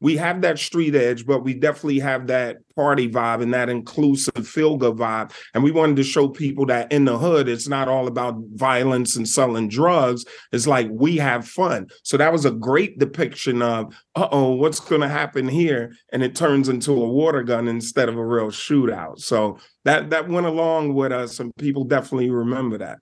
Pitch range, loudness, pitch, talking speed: 120-145 Hz, -20 LUFS, 130 Hz, 205 wpm